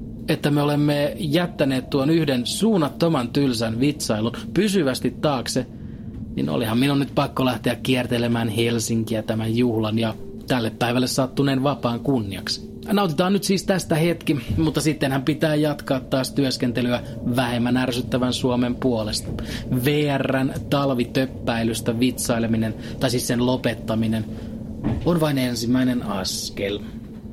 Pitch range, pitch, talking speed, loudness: 115-145 Hz, 125 Hz, 115 wpm, -22 LUFS